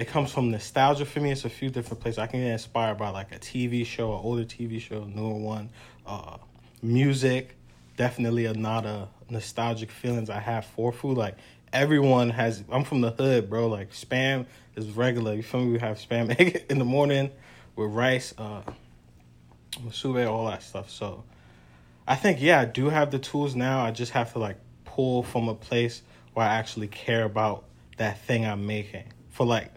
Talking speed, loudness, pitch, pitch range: 200 wpm, -27 LUFS, 115 Hz, 110-125 Hz